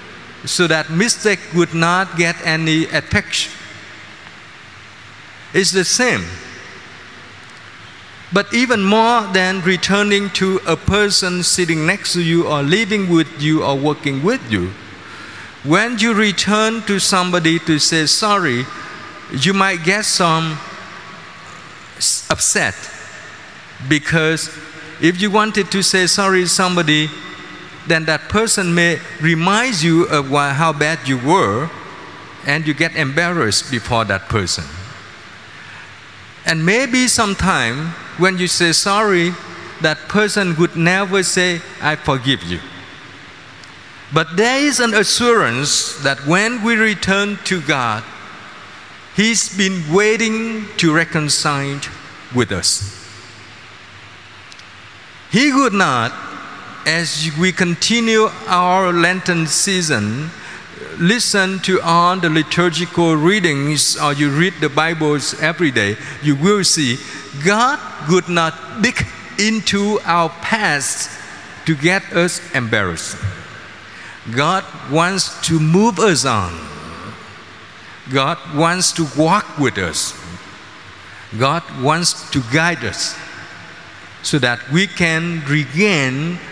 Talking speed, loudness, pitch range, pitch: 115 wpm, -15 LUFS, 135-190 Hz, 165 Hz